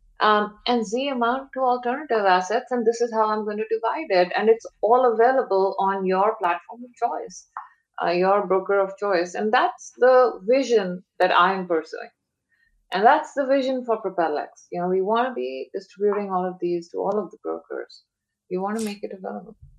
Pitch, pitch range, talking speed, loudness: 215 Hz, 190-245 Hz, 195 wpm, -22 LUFS